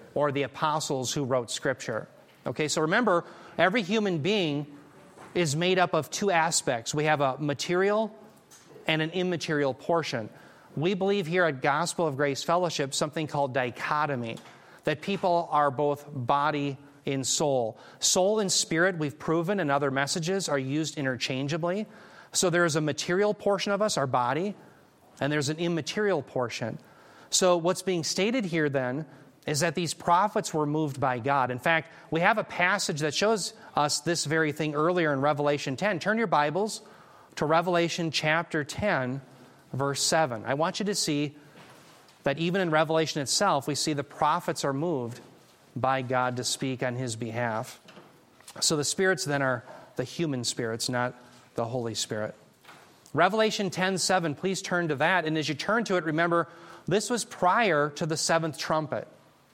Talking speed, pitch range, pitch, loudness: 165 wpm, 140-180 Hz, 155 Hz, -27 LUFS